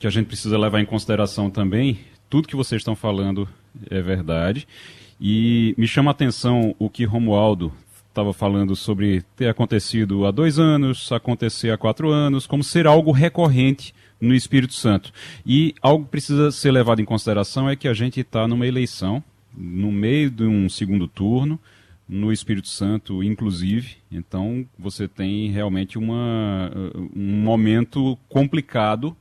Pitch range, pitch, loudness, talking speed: 100-130 Hz, 110 Hz, -20 LUFS, 155 wpm